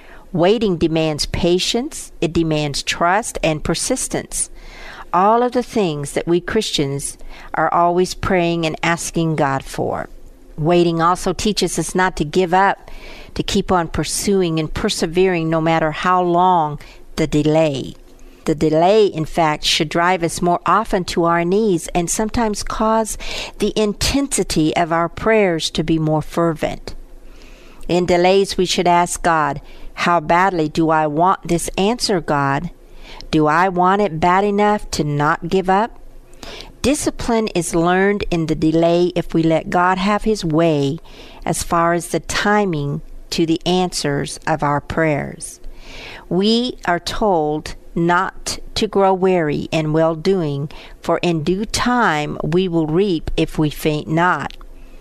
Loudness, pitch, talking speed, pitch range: -17 LUFS, 175 Hz, 145 wpm, 160-190 Hz